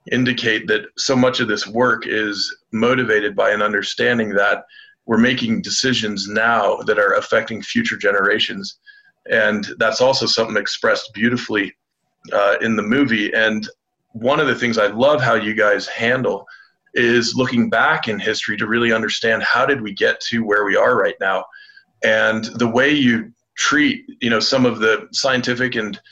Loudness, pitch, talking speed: -17 LUFS, 130 Hz, 170 wpm